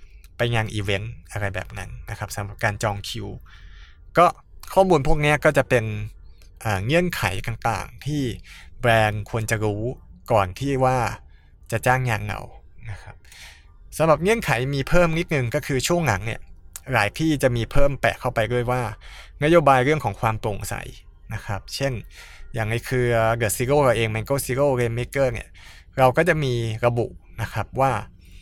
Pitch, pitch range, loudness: 115 Hz, 100-130 Hz, -22 LUFS